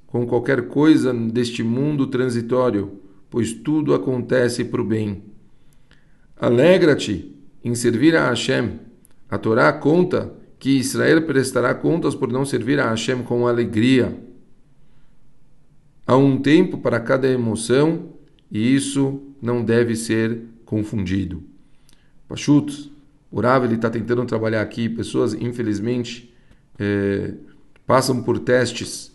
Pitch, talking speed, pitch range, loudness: 120 Hz, 115 wpm, 115-135 Hz, -19 LUFS